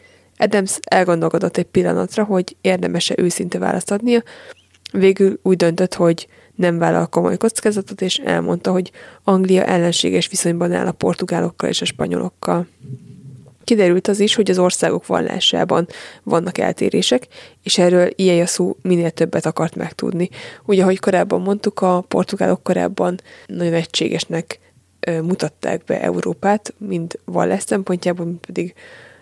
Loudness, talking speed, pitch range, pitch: -18 LUFS, 130 wpm, 170-200 Hz, 180 Hz